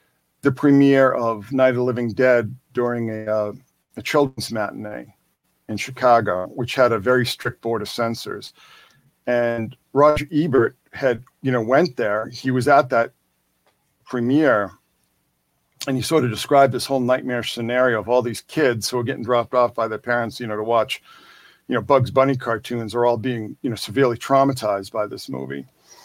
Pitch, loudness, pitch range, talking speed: 120 Hz, -20 LUFS, 115-130 Hz, 175 wpm